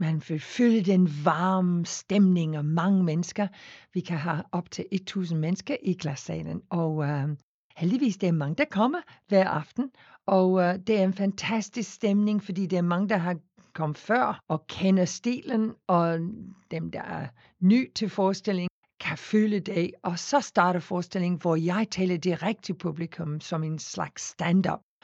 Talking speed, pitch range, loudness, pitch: 170 wpm, 170-205 Hz, -27 LUFS, 185 Hz